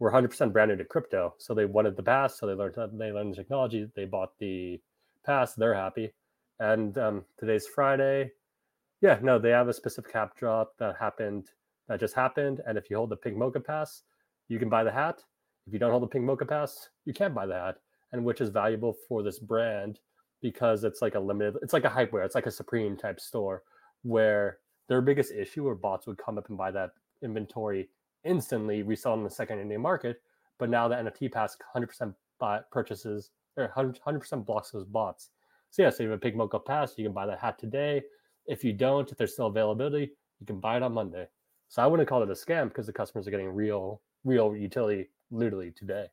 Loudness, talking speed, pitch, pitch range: -30 LUFS, 220 wpm, 110 Hz, 105-130 Hz